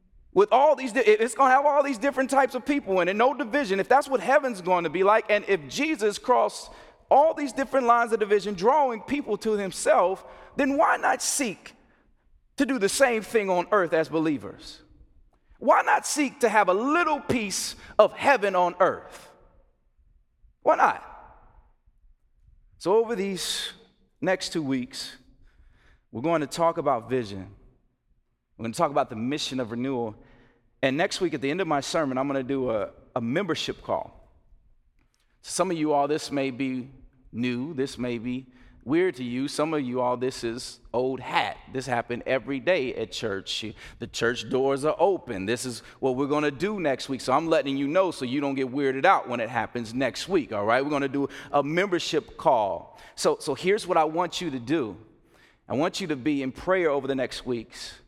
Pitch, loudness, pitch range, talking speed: 155 Hz, -25 LUFS, 130-210 Hz, 190 wpm